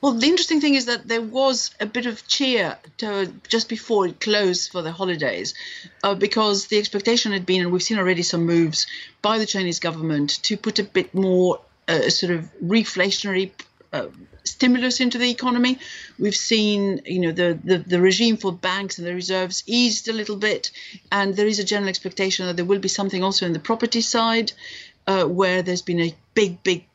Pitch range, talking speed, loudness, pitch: 185-230 Hz, 200 wpm, -21 LUFS, 200 Hz